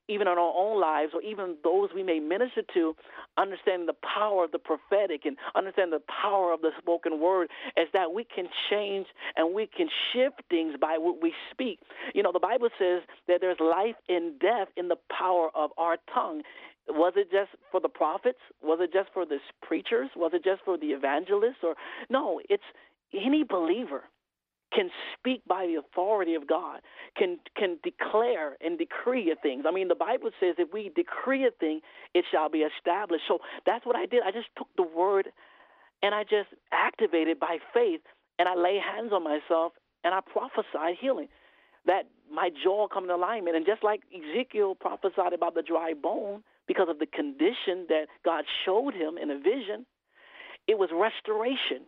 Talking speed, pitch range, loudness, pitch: 185 wpm, 170-260 Hz, -29 LUFS, 195 Hz